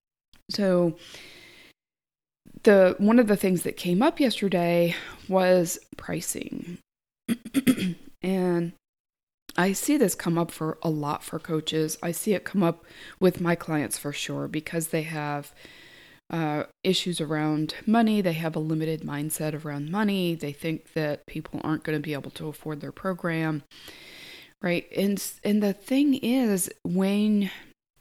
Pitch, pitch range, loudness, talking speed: 170 Hz, 155-200 Hz, -26 LUFS, 145 wpm